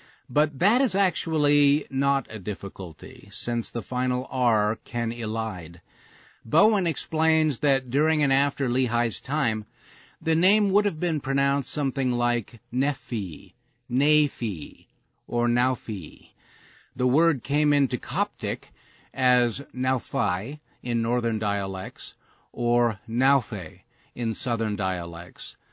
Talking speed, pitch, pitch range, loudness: 110 wpm, 125 Hz, 115-145 Hz, -25 LUFS